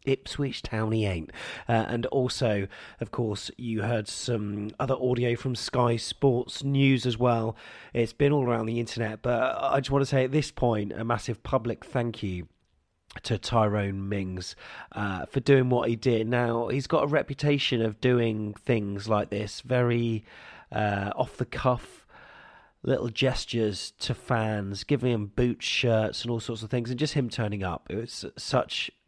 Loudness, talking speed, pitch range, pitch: -28 LUFS, 175 wpm, 105-125 Hz, 120 Hz